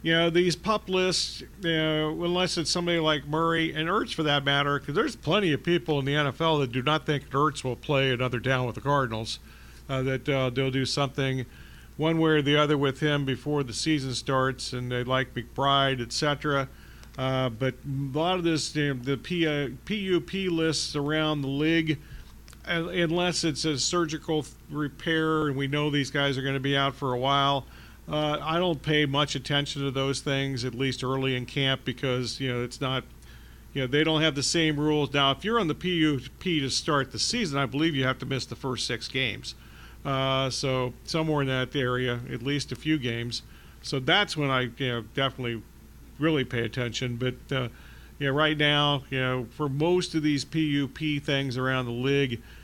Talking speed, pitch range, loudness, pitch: 210 wpm, 130-155 Hz, -27 LUFS, 140 Hz